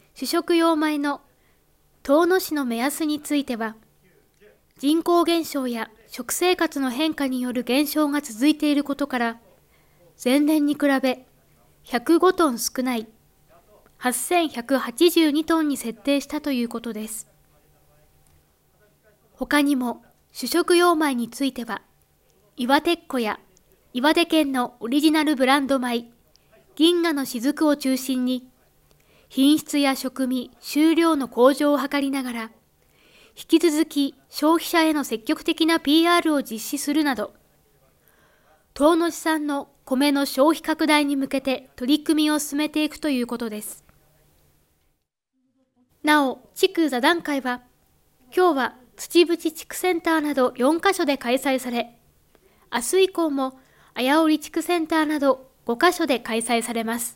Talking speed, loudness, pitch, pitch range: 240 characters per minute, -22 LUFS, 285 Hz, 250-315 Hz